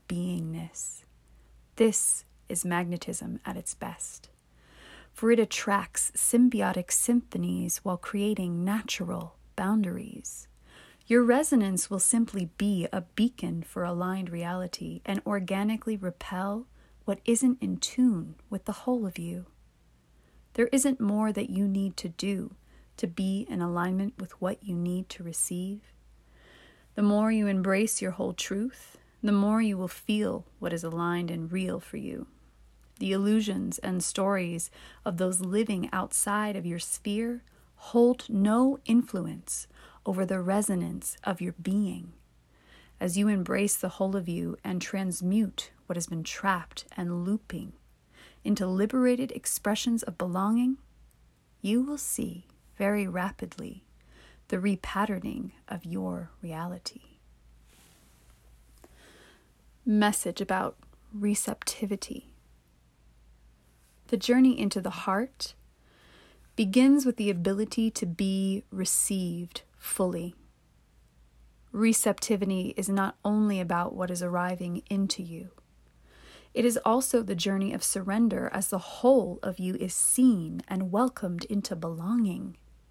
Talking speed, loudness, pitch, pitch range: 120 wpm, -29 LUFS, 195 Hz, 175-215 Hz